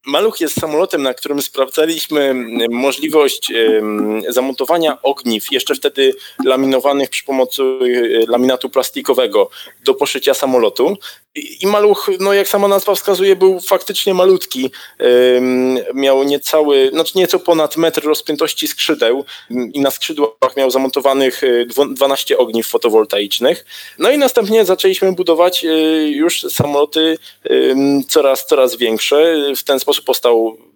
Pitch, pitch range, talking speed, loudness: 155 Hz, 130-200 Hz, 115 wpm, -14 LUFS